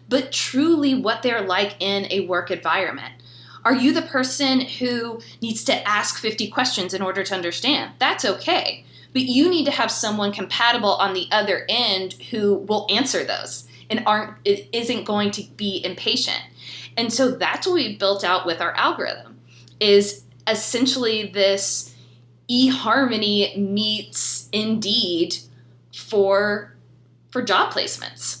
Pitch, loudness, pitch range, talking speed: 205 Hz, -21 LUFS, 185-235 Hz, 140 wpm